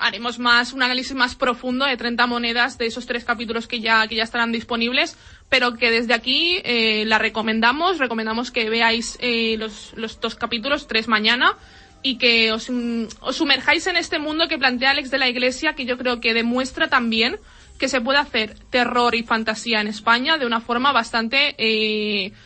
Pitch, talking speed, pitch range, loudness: 240 Hz, 190 wpm, 230-260 Hz, -19 LUFS